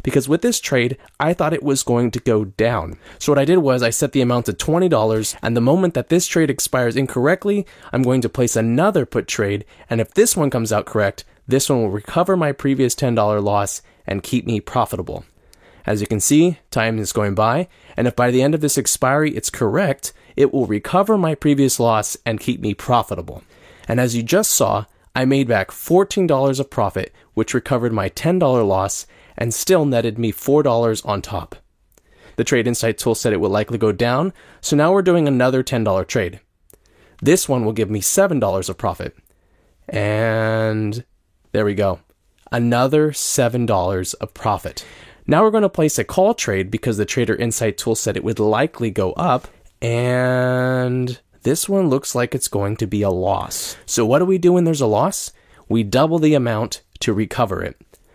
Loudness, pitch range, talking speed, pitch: -18 LUFS, 105-140 Hz, 190 wpm, 120 Hz